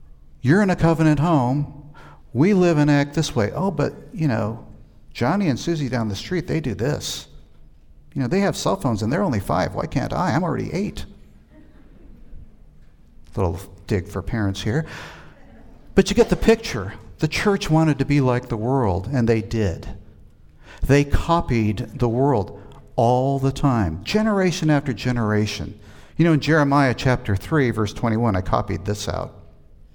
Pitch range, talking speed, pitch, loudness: 100-145 Hz, 170 wpm, 120 Hz, -21 LUFS